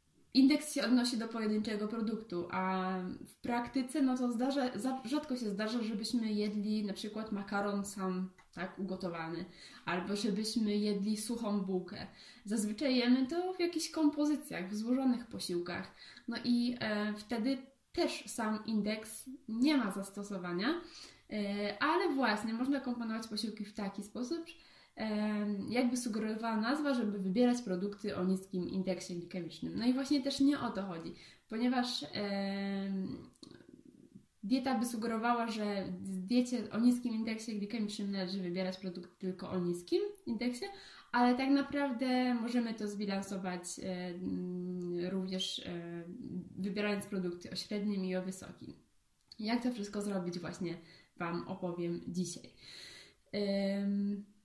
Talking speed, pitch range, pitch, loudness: 130 wpm, 190-245 Hz, 215 Hz, -36 LUFS